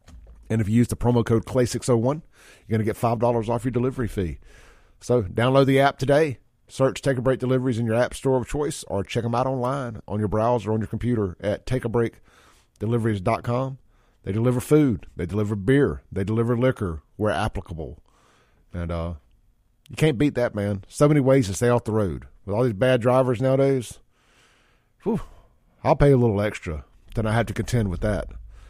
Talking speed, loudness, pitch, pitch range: 190 wpm, -23 LUFS, 115 Hz, 105-130 Hz